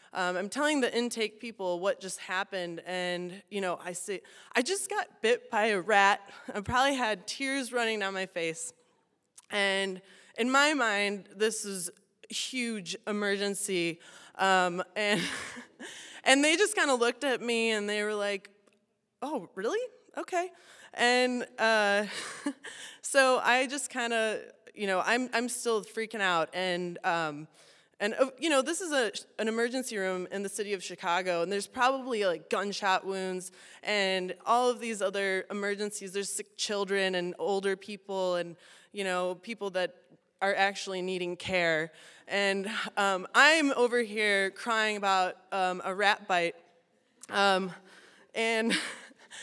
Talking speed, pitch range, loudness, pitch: 150 wpm, 190-235 Hz, -29 LUFS, 205 Hz